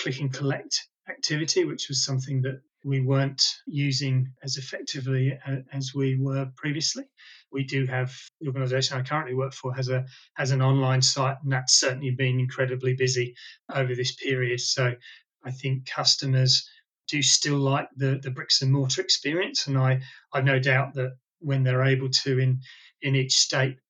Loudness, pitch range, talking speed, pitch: -25 LUFS, 130-135 Hz, 170 wpm, 135 Hz